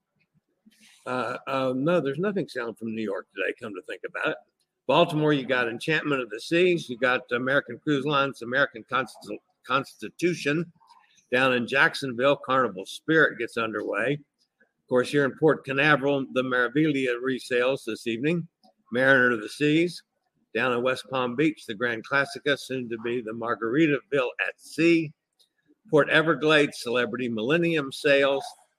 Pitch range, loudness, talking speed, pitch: 125-160 Hz, -25 LUFS, 150 wpm, 140 Hz